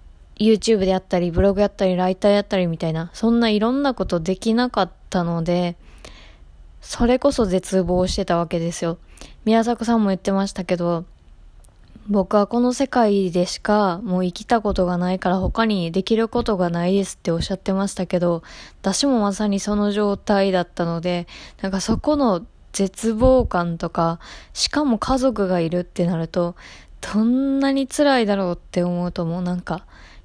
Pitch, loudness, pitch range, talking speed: 190 Hz, -20 LUFS, 175-225 Hz, 355 characters per minute